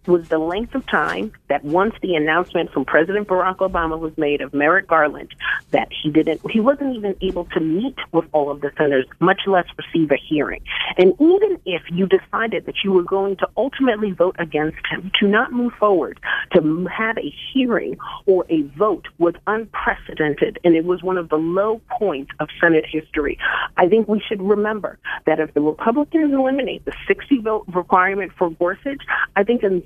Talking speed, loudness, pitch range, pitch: 190 wpm, -19 LUFS, 160-220 Hz, 185 Hz